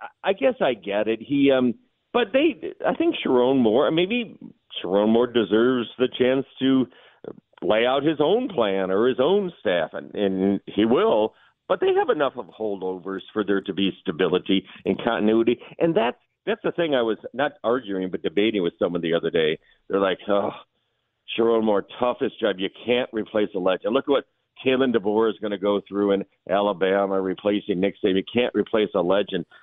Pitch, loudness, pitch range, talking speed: 110 Hz, -23 LUFS, 100-130 Hz, 190 wpm